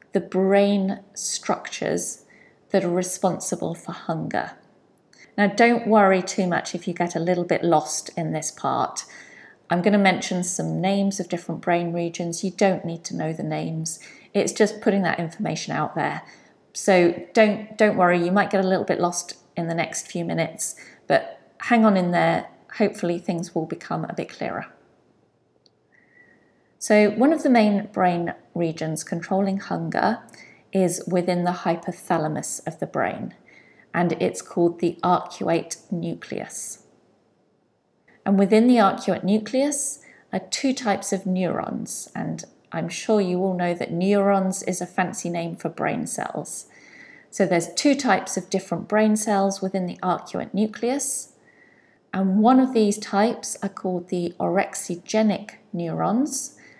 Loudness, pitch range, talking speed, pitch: -23 LUFS, 175-210 Hz, 150 wpm, 190 Hz